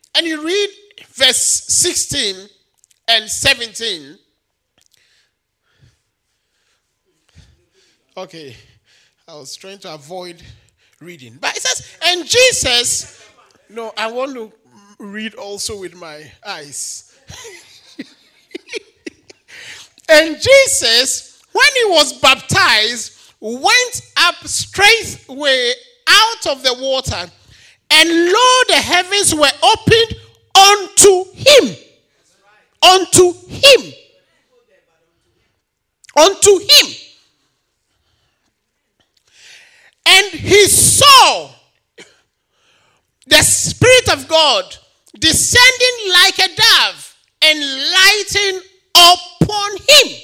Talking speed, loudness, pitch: 80 wpm, -10 LUFS, 335 Hz